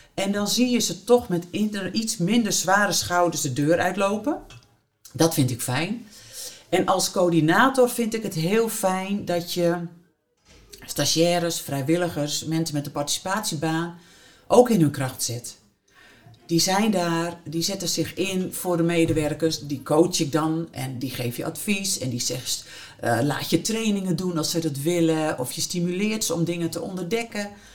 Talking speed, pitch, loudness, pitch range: 170 wpm, 170 Hz, -23 LUFS, 150-190 Hz